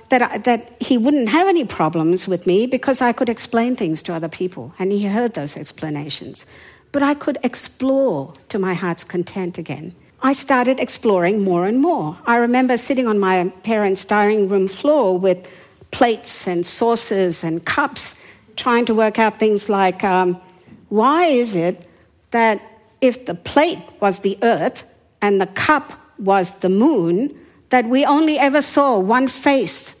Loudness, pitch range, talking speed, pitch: -17 LUFS, 185-255 Hz, 165 wpm, 220 Hz